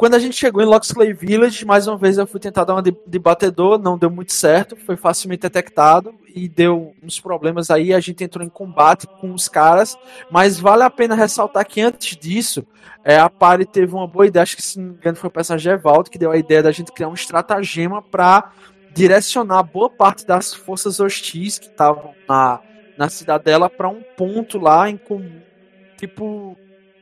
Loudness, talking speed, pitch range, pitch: -15 LUFS, 200 wpm, 170-205 Hz, 185 Hz